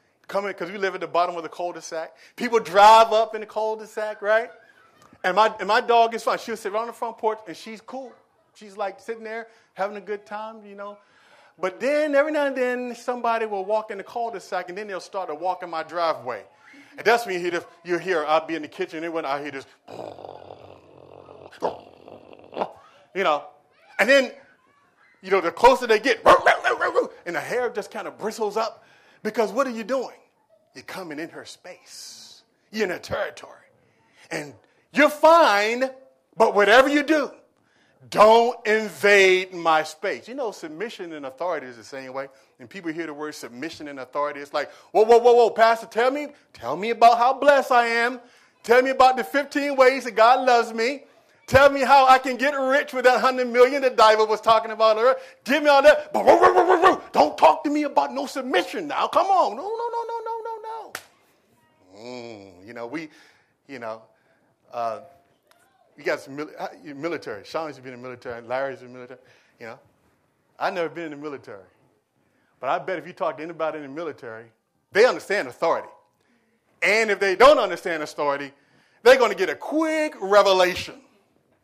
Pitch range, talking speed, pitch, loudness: 170-260 Hz, 195 wpm, 215 Hz, -21 LUFS